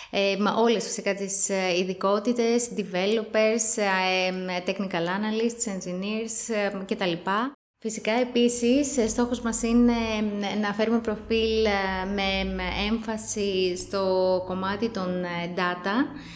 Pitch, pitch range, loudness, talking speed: 205 Hz, 190-225 Hz, -25 LUFS, 90 wpm